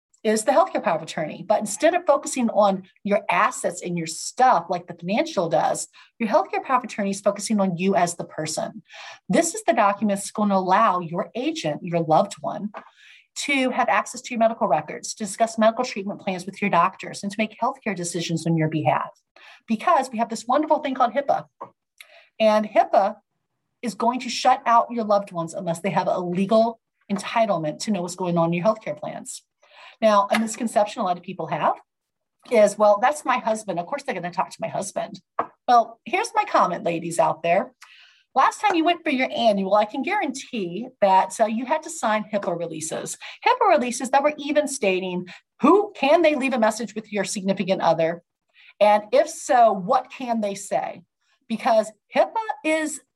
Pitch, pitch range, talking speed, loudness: 215 Hz, 190-255 Hz, 195 wpm, -22 LUFS